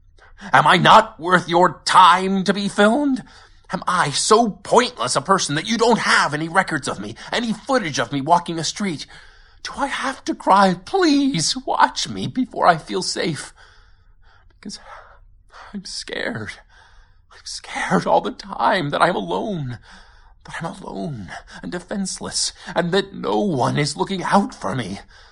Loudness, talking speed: -19 LUFS, 160 wpm